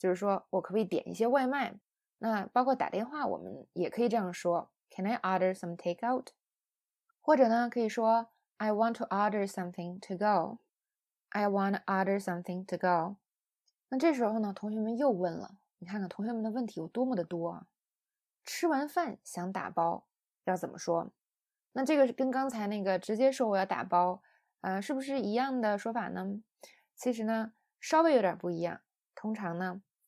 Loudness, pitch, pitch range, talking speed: -32 LUFS, 210 Hz, 185-245 Hz, 355 characters per minute